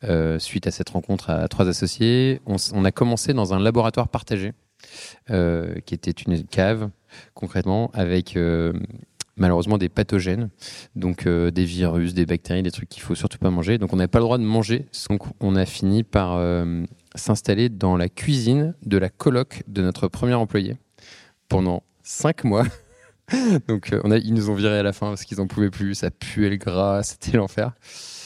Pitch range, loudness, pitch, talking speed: 90-115 Hz, -22 LUFS, 100 Hz, 200 wpm